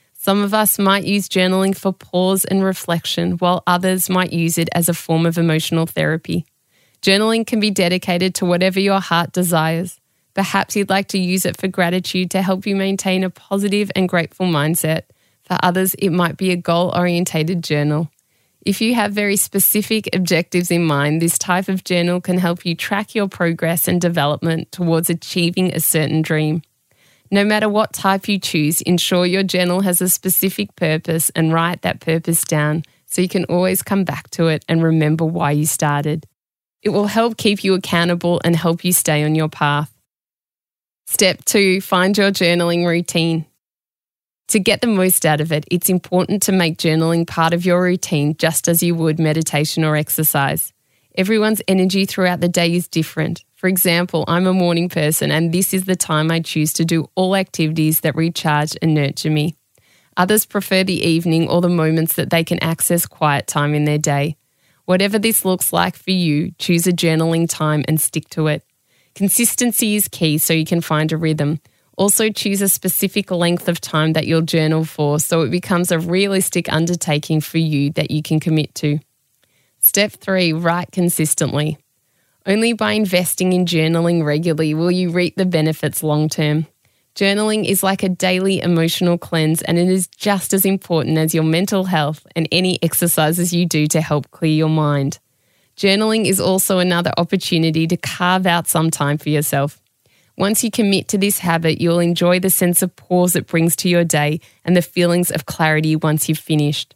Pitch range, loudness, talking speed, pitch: 155-185 Hz, -17 LUFS, 185 wpm, 170 Hz